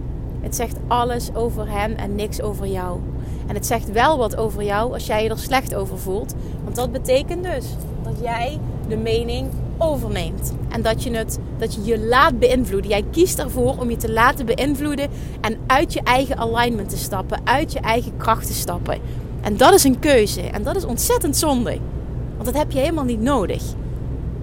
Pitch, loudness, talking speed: 245 Hz, -20 LUFS, 195 wpm